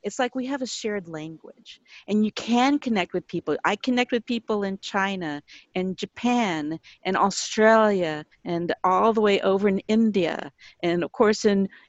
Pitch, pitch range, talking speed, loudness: 205 Hz, 180-230 Hz, 170 wpm, -24 LUFS